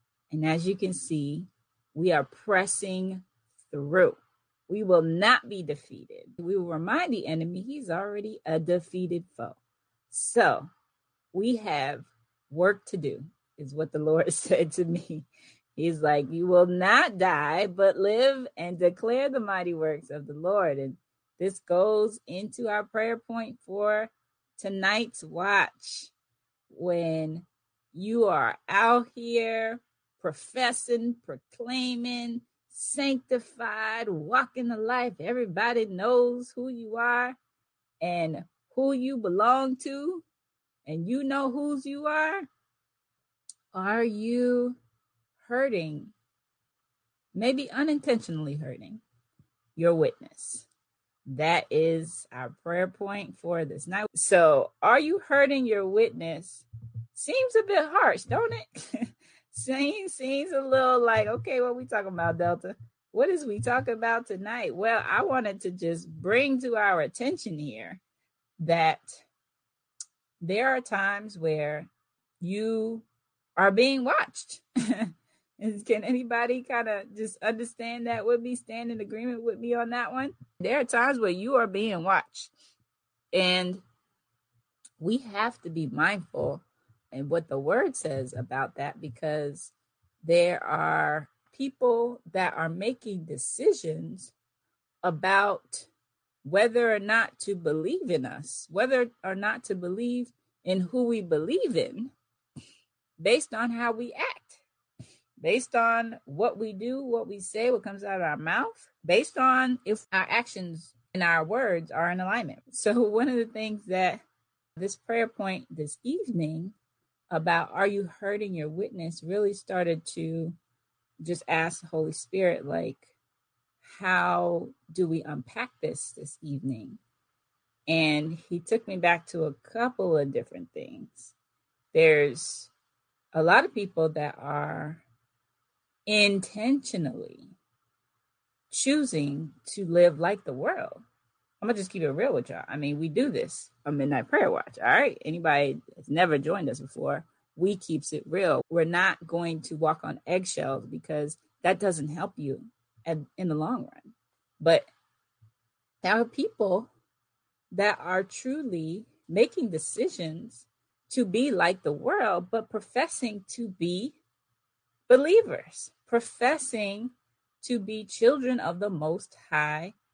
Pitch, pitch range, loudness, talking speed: 195 Hz, 160-235 Hz, -28 LUFS, 135 wpm